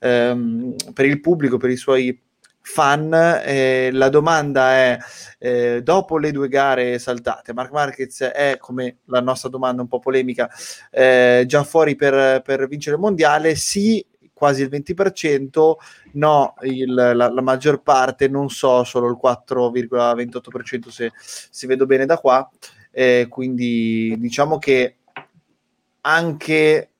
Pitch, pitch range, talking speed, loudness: 130 Hz, 125-145 Hz, 140 wpm, -18 LUFS